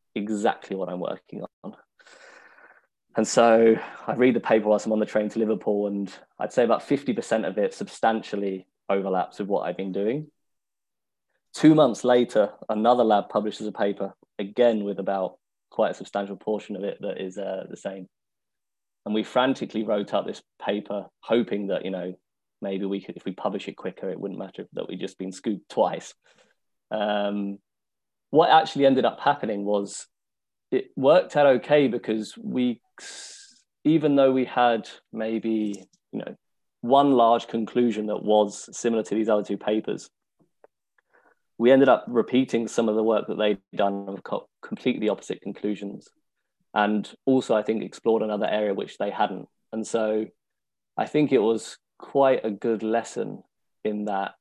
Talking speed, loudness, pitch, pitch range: 165 wpm, -24 LUFS, 110 Hz, 100-120 Hz